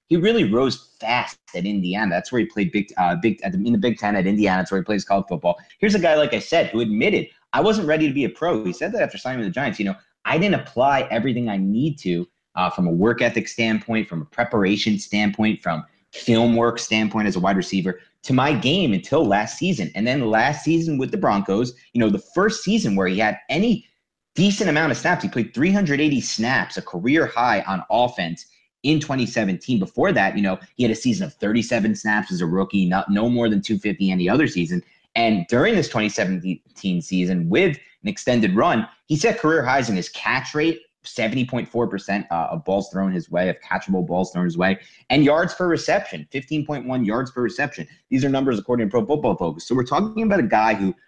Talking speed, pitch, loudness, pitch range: 225 wpm, 115 Hz, -21 LUFS, 95-150 Hz